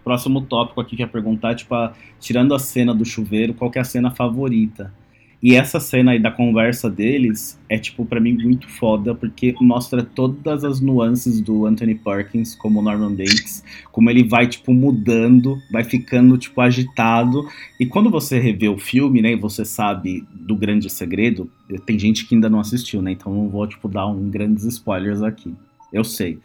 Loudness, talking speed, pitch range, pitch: -18 LUFS, 185 wpm, 110-125 Hz, 115 Hz